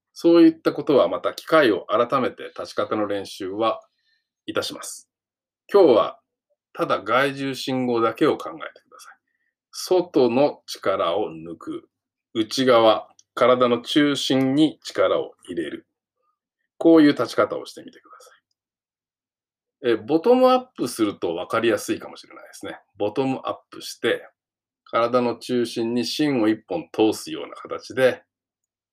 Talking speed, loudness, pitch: 270 characters per minute, -21 LUFS, 145 Hz